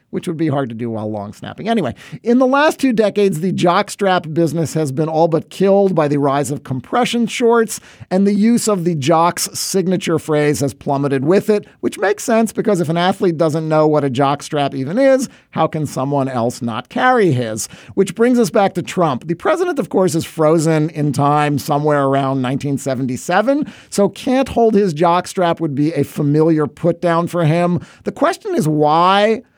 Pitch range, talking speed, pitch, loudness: 145-200 Hz, 195 wpm, 165 Hz, -16 LUFS